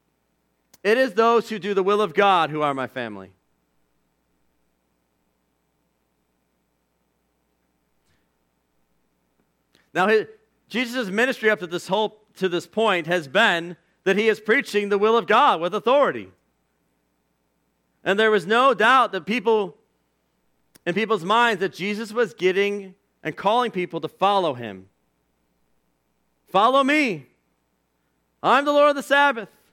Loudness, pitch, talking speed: -21 LUFS, 160 Hz, 125 wpm